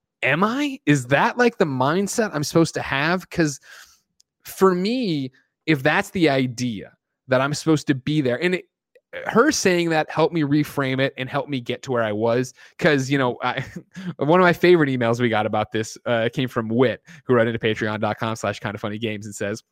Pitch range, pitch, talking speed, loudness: 120-170 Hz, 140 Hz, 210 wpm, -21 LUFS